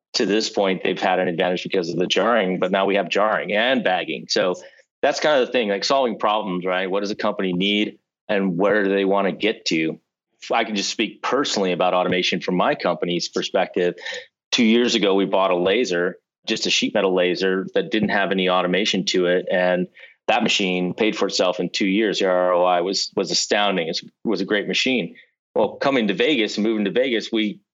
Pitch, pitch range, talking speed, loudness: 95 Hz, 90-105 Hz, 215 wpm, -20 LUFS